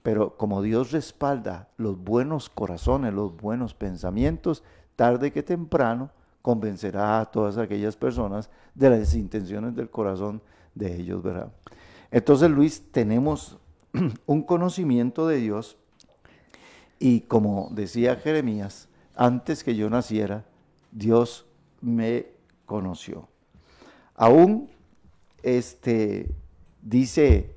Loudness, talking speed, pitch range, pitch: -24 LUFS, 100 wpm, 100-125 Hz, 115 Hz